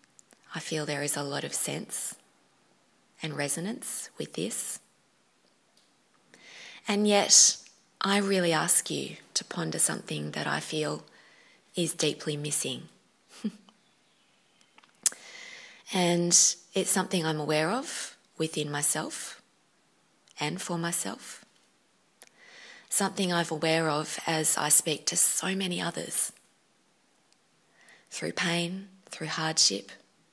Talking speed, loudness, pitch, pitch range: 105 wpm, -27 LUFS, 170 Hz, 155-195 Hz